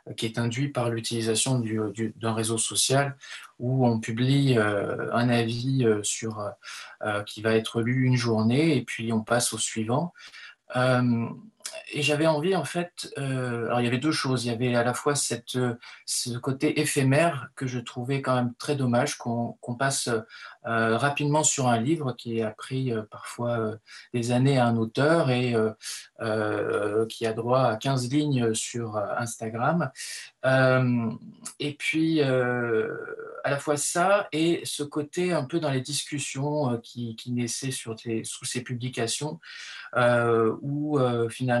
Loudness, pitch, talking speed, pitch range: -26 LUFS, 125 Hz, 170 wpm, 115-145 Hz